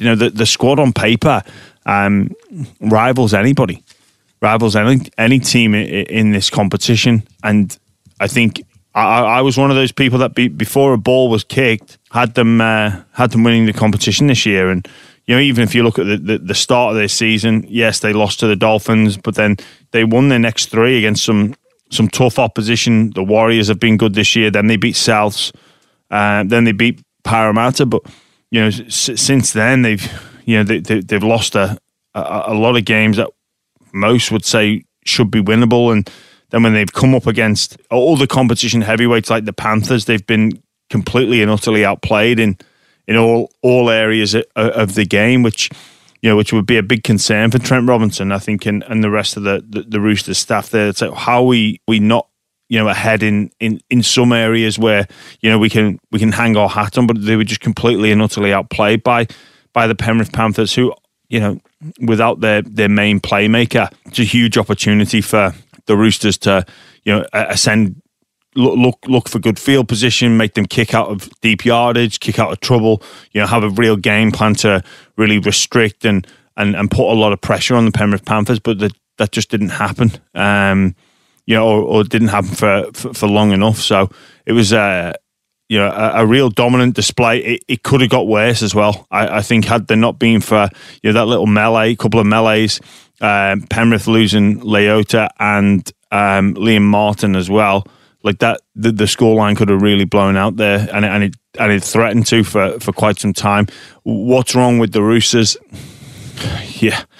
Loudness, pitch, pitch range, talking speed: -13 LUFS, 110 Hz, 105-115 Hz, 205 wpm